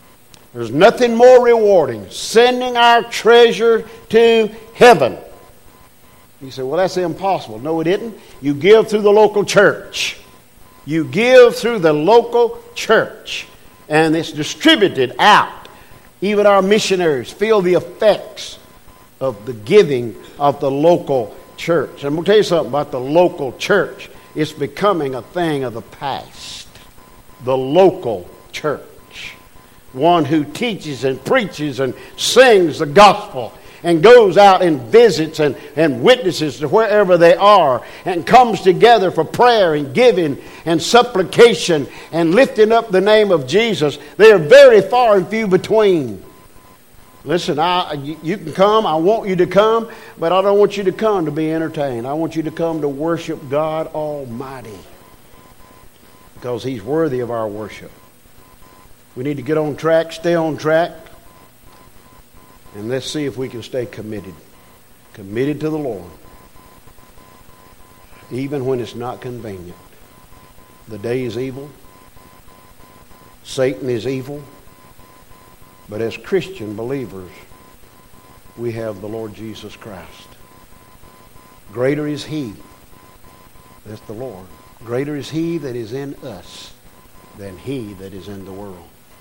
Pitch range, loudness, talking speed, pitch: 125-200 Hz, -14 LUFS, 140 wpm, 155 Hz